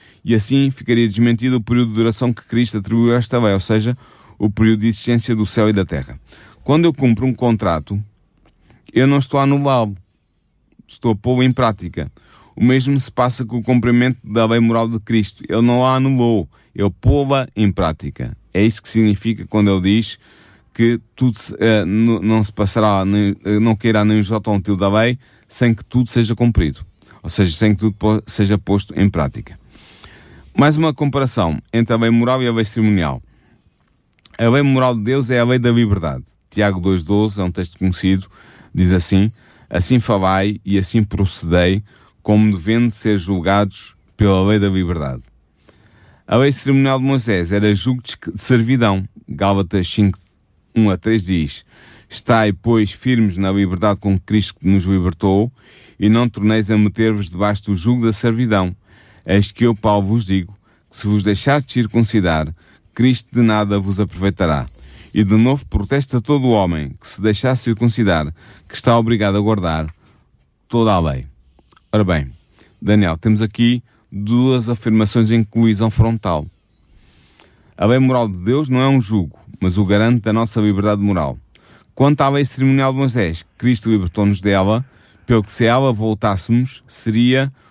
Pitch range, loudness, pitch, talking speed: 100-120 Hz, -16 LUFS, 110 Hz, 175 wpm